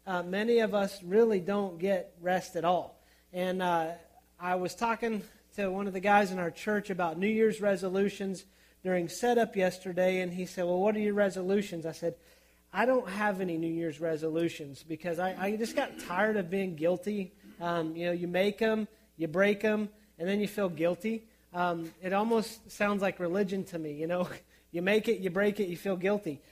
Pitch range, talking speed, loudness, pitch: 175-205 Hz, 200 wpm, -31 LUFS, 190 Hz